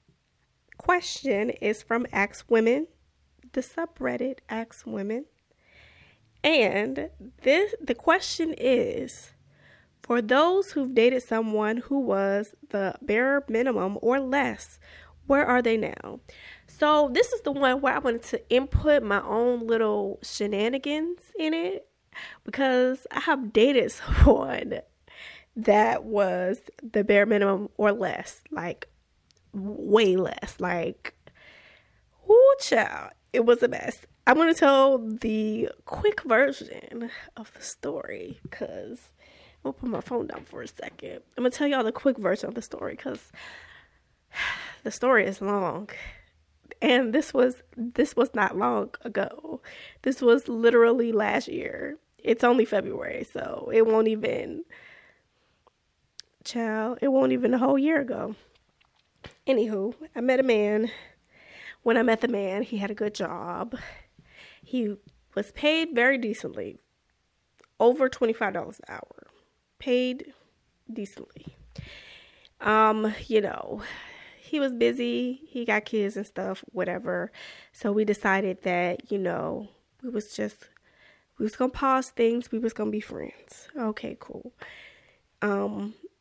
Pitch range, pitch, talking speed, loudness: 210-270 Hz, 235 Hz, 130 wpm, -25 LUFS